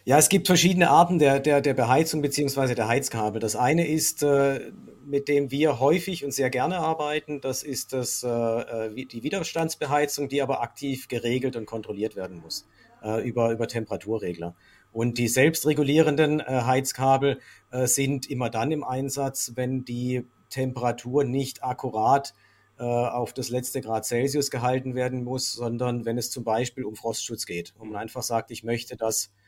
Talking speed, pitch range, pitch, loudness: 155 wpm, 115-140 Hz, 130 Hz, -25 LUFS